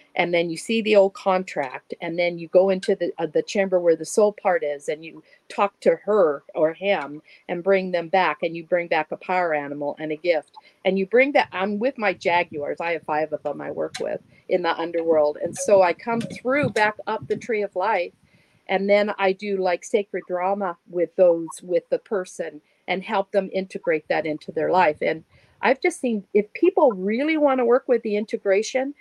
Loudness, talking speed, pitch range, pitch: -23 LUFS, 215 wpm, 170-210 Hz, 190 Hz